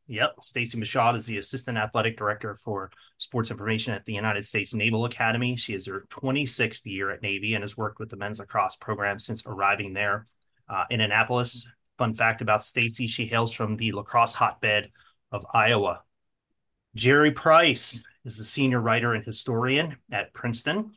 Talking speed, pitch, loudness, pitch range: 170 wpm, 115 Hz, -25 LUFS, 105-120 Hz